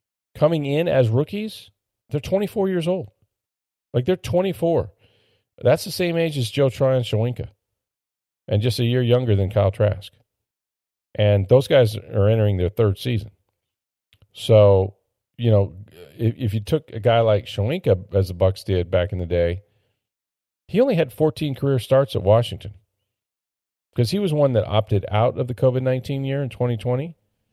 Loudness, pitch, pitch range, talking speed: -21 LUFS, 110 Hz, 100-130 Hz, 170 wpm